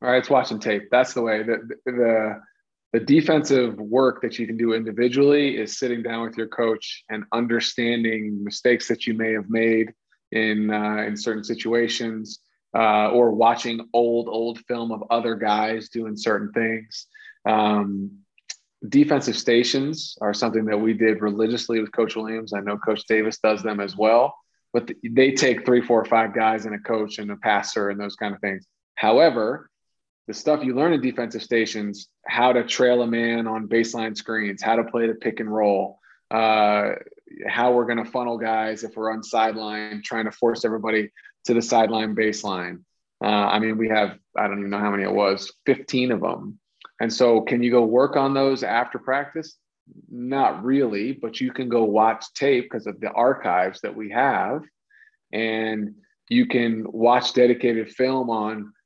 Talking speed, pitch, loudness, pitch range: 180 wpm, 115 Hz, -22 LUFS, 110-120 Hz